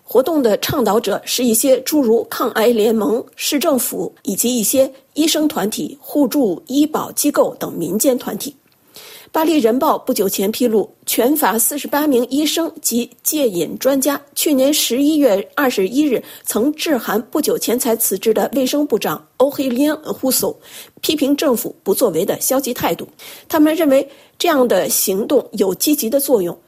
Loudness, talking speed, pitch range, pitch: -16 LUFS, 255 characters per minute, 240-300 Hz, 270 Hz